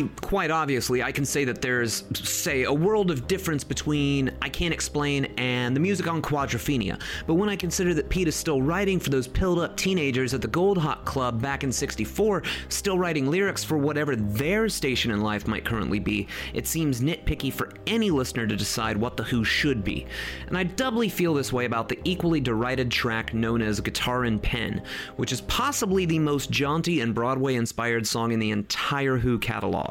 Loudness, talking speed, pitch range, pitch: -25 LUFS, 200 wpm, 115-165 Hz, 135 Hz